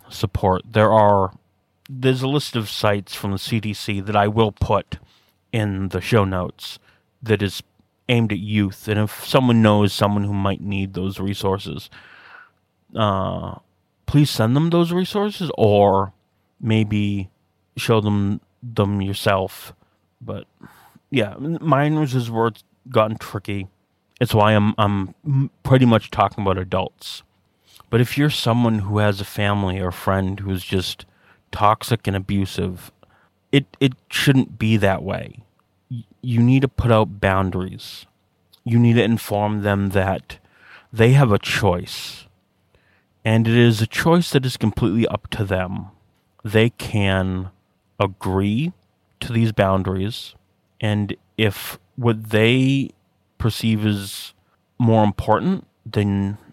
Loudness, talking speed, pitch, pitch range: -20 LUFS, 135 wpm, 105 Hz, 95-115 Hz